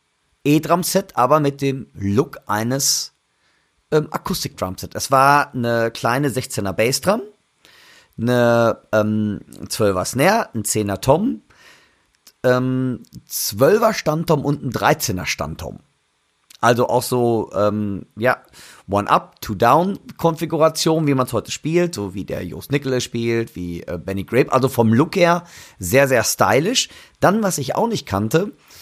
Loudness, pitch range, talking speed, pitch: -19 LUFS, 110-150 Hz, 125 wpm, 125 Hz